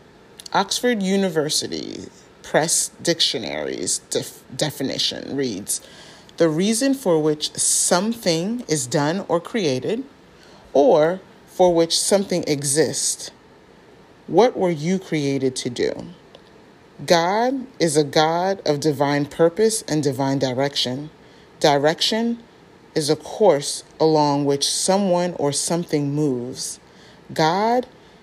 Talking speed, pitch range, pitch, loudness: 100 wpm, 145-190 Hz, 165 Hz, -20 LUFS